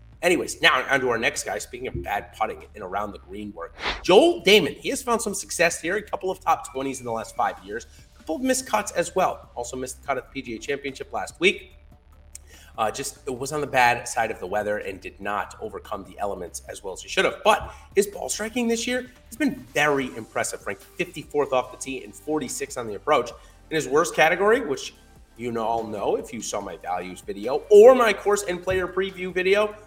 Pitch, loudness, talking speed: 150 Hz, -24 LUFS, 235 wpm